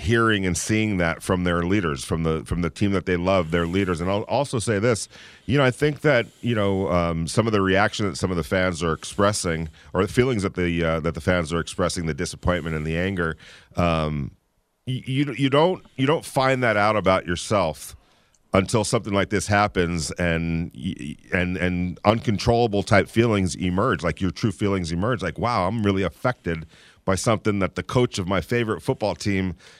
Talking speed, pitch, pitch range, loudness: 205 wpm, 95 Hz, 85-110 Hz, -23 LUFS